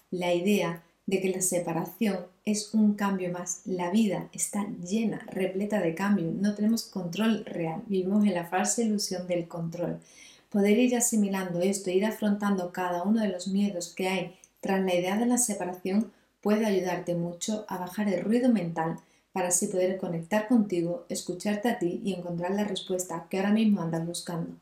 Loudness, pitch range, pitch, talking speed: -28 LUFS, 175-210 Hz, 190 Hz, 180 wpm